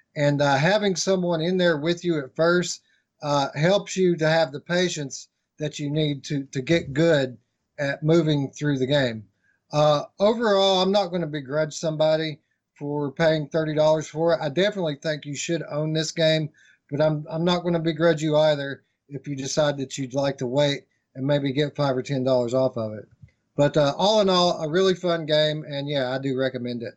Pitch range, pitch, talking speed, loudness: 140-165 Hz, 150 Hz, 205 wpm, -23 LUFS